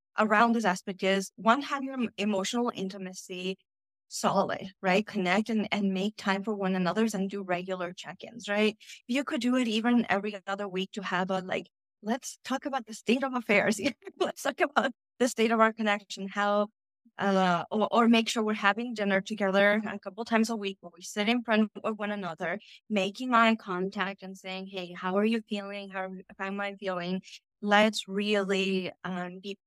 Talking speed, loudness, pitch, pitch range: 195 wpm, -29 LUFS, 205 Hz, 190-225 Hz